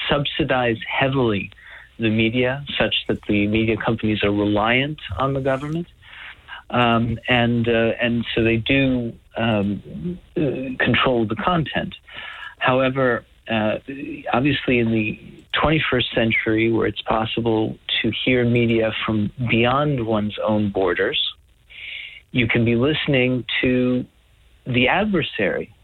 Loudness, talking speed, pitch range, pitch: -20 LUFS, 115 wpm, 110-135 Hz, 120 Hz